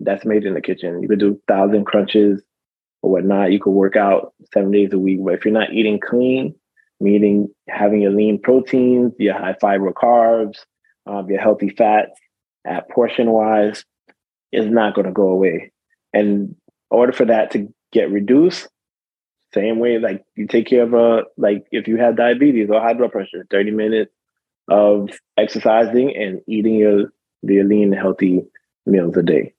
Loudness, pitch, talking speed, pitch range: -16 LUFS, 105 Hz, 175 wpm, 100-115 Hz